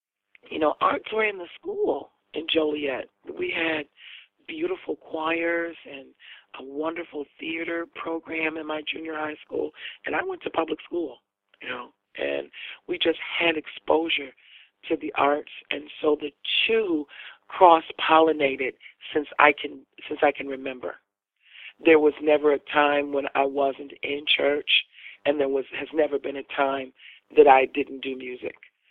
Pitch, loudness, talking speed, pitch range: 150 Hz, -25 LUFS, 155 wpm, 140-165 Hz